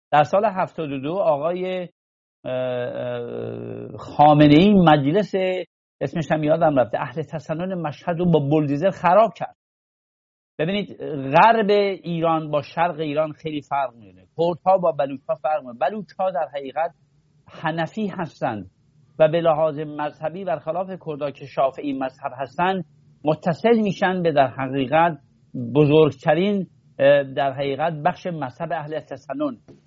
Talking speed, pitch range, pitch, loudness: 130 wpm, 140-175 Hz, 155 Hz, -21 LUFS